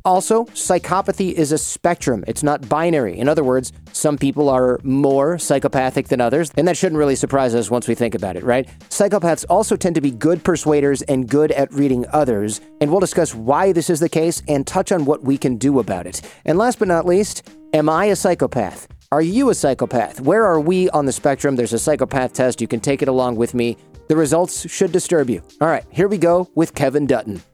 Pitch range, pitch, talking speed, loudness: 130-175 Hz, 150 Hz, 220 wpm, -18 LUFS